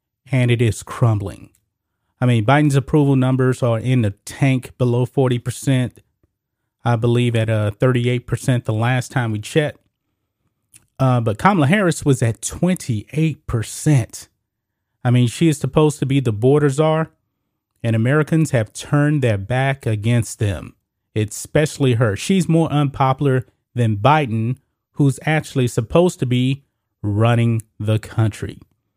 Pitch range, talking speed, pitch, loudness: 110-140 Hz, 140 wpm, 125 Hz, -18 LUFS